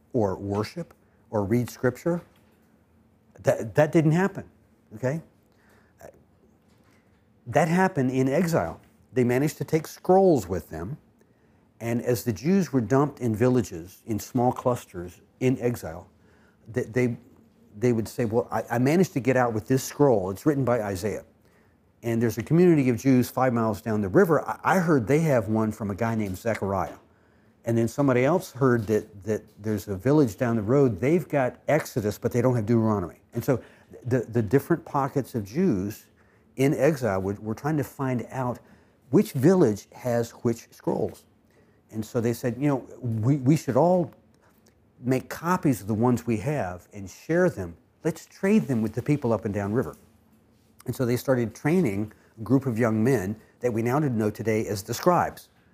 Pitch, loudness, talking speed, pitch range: 120 Hz, -25 LUFS, 180 wpm, 105-135 Hz